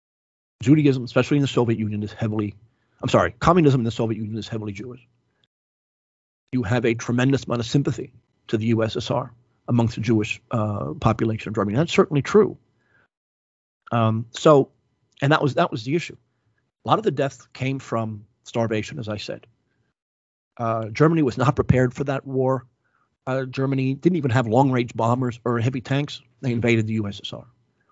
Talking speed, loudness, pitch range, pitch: 170 wpm, -22 LUFS, 110-135 Hz, 120 Hz